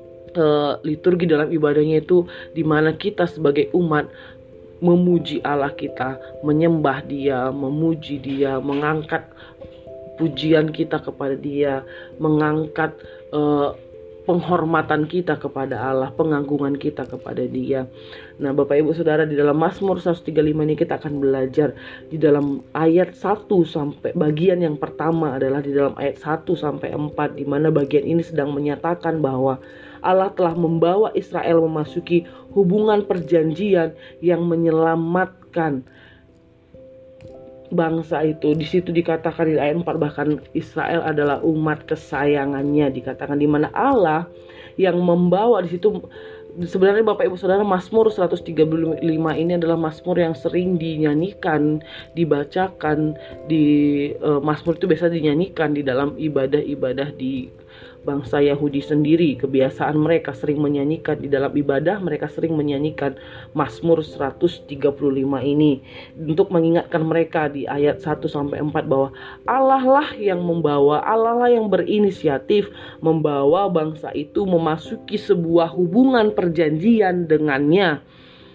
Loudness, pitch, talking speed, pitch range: -20 LUFS, 155 Hz, 120 wpm, 145-170 Hz